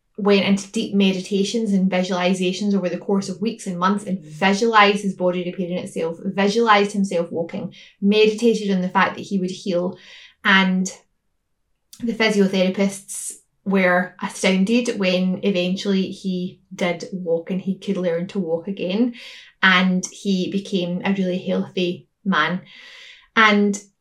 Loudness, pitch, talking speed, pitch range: -20 LUFS, 190 Hz, 135 wpm, 180-205 Hz